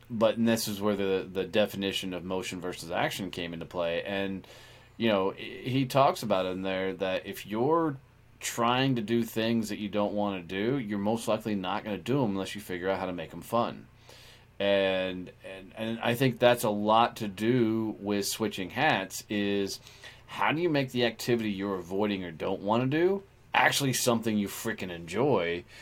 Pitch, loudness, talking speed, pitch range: 105 Hz, -29 LUFS, 200 wpm, 95-120 Hz